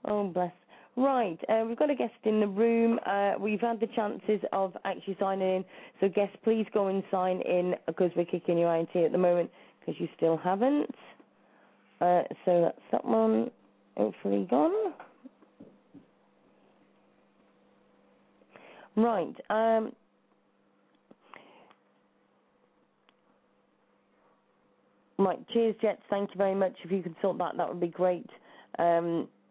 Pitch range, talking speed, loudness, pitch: 175-220 Hz, 130 wpm, -29 LUFS, 195 Hz